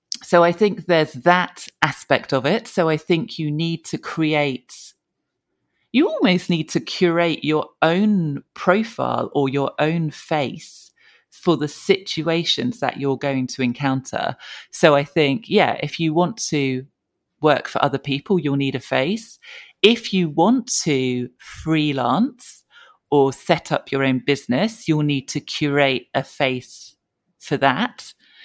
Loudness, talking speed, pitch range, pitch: -20 LUFS, 150 wpm, 140-180 Hz, 155 Hz